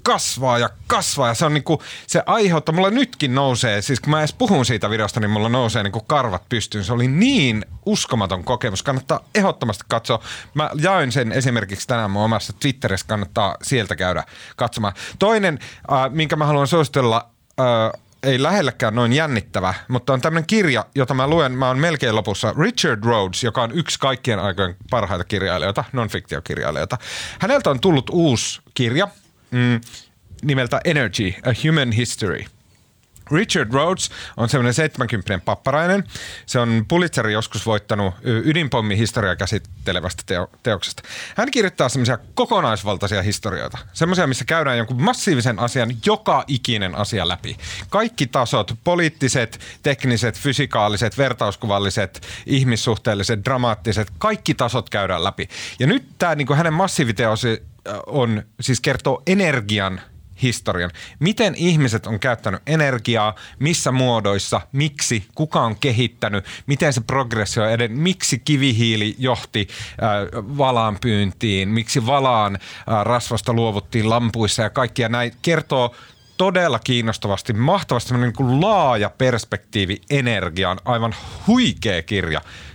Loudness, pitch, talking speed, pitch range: -19 LUFS, 120 Hz, 130 wpm, 105-140 Hz